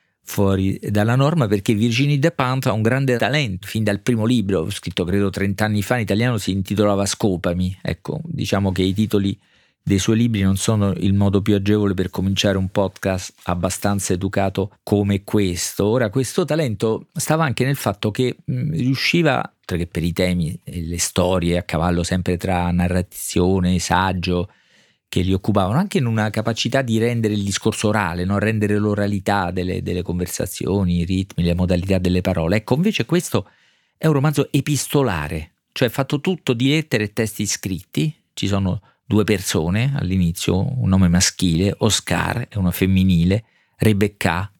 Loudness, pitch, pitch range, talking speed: -20 LUFS, 100 Hz, 95-115 Hz, 165 wpm